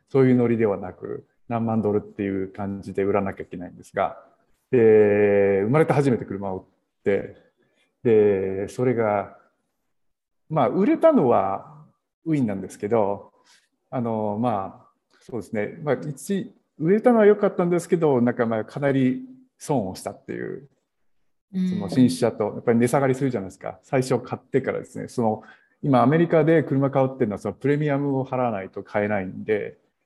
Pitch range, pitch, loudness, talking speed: 105-155 Hz, 125 Hz, -23 LUFS, 330 characters per minute